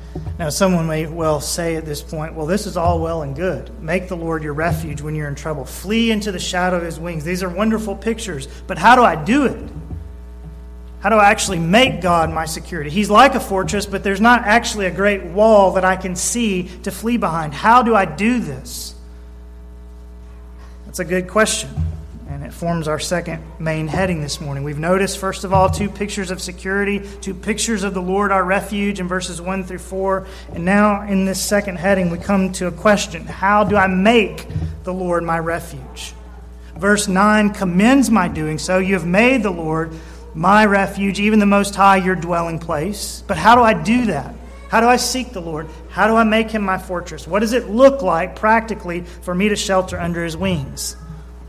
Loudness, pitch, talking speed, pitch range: -17 LUFS, 185 Hz, 205 wpm, 160-205 Hz